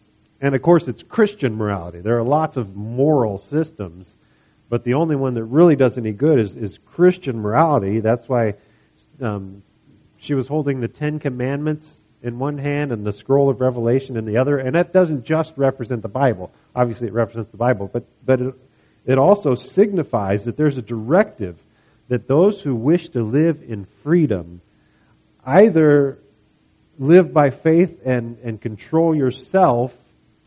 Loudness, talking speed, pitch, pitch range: -19 LUFS, 165 wpm, 130 Hz, 115-150 Hz